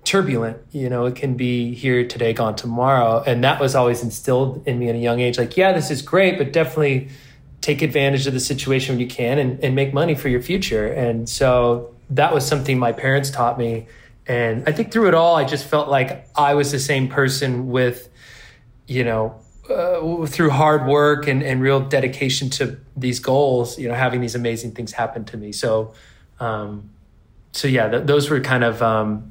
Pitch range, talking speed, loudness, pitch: 120-140 Hz, 205 wpm, -19 LUFS, 130 Hz